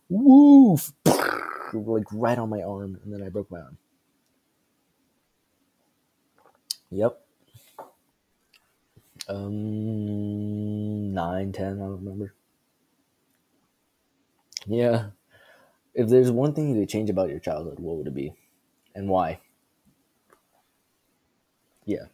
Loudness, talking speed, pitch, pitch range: -23 LUFS, 100 wpm, 105 Hz, 100-120 Hz